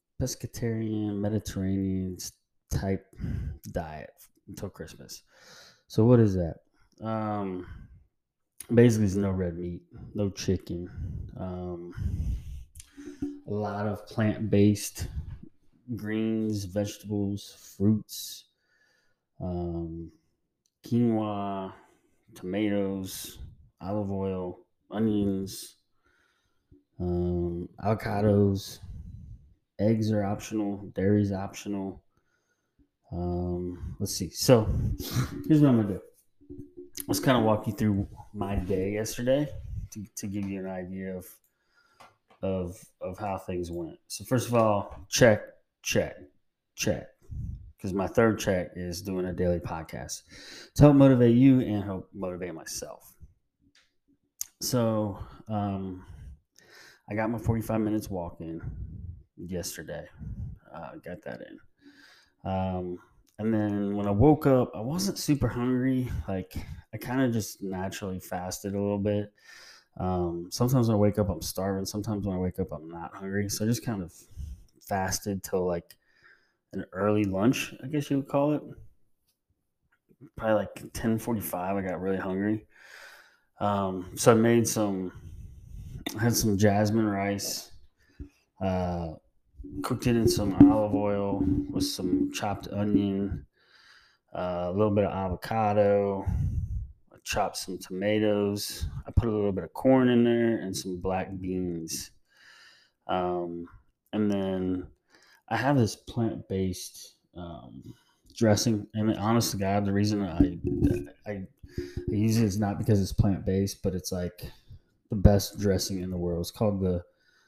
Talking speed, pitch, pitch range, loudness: 130 wpm, 100 Hz, 90-110 Hz, -28 LUFS